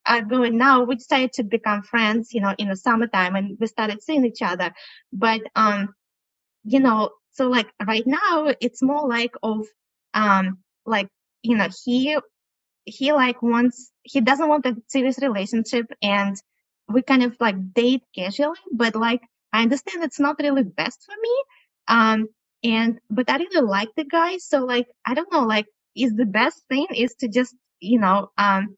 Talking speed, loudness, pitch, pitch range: 180 wpm, -21 LUFS, 240 Hz, 215-270 Hz